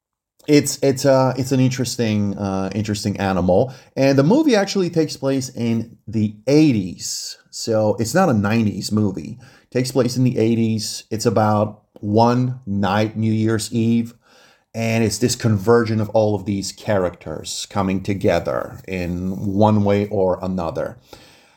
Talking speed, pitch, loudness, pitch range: 145 wpm, 110 Hz, -19 LUFS, 100-125 Hz